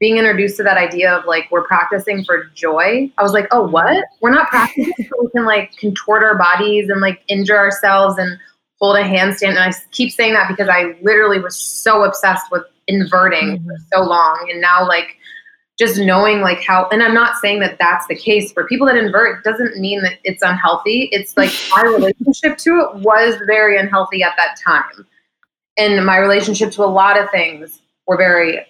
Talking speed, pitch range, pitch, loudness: 205 wpm, 185-220 Hz, 200 Hz, -13 LUFS